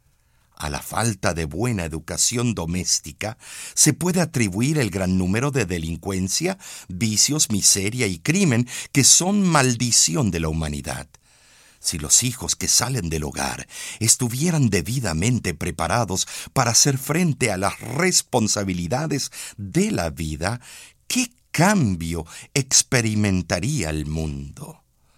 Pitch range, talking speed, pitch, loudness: 85-135 Hz, 115 wpm, 105 Hz, -20 LUFS